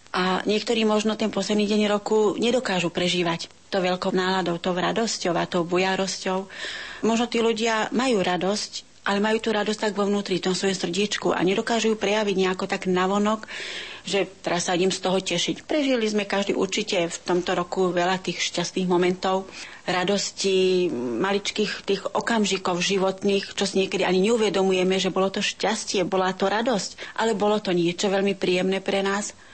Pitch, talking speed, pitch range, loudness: 195 Hz, 170 wpm, 185-210 Hz, -24 LUFS